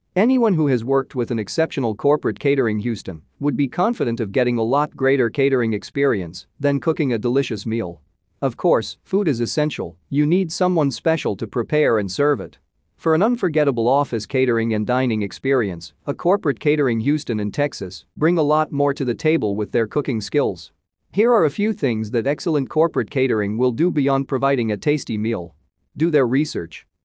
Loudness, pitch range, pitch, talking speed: -20 LUFS, 115-150 Hz, 135 Hz, 185 wpm